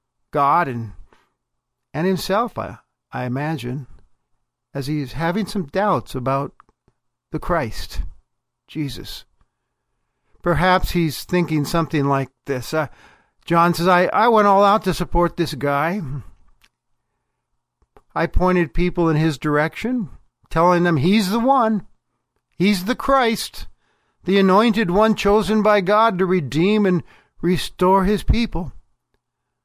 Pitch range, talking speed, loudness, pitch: 140-200 Hz, 120 wpm, -19 LUFS, 175 Hz